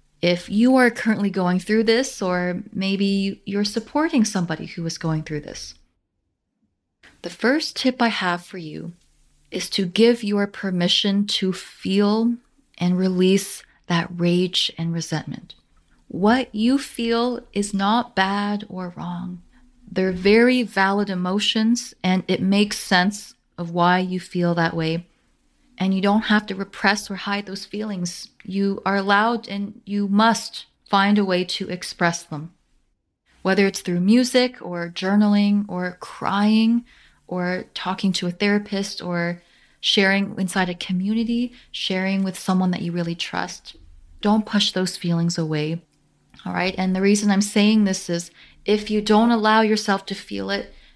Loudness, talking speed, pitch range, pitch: -21 LUFS, 150 wpm, 180-210 Hz, 195 Hz